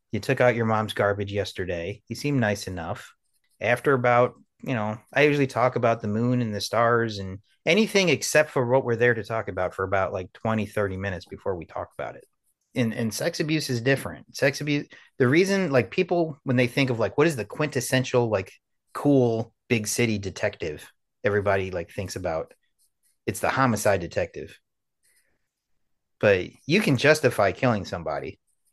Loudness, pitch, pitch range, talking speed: -24 LUFS, 120 Hz, 105-135 Hz, 180 wpm